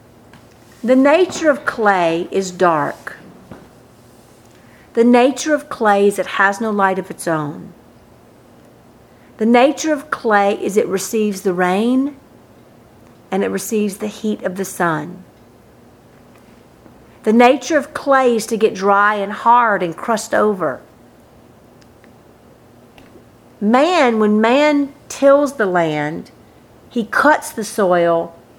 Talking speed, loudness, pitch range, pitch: 120 wpm, -16 LUFS, 195-255 Hz, 215 Hz